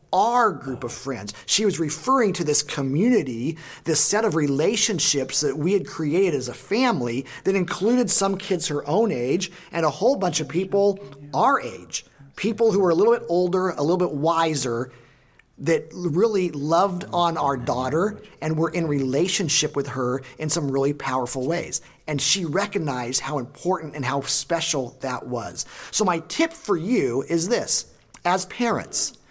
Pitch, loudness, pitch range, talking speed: 165 Hz, -23 LUFS, 140-190 Hz, 170 wpm